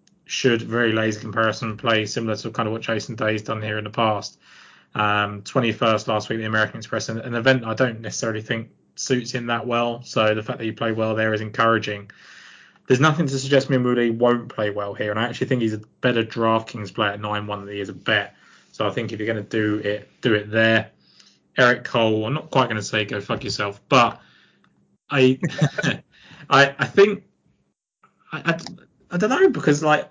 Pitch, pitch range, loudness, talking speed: 115 Hz, 110-125 Hz, -22 LUFS, 205 wpm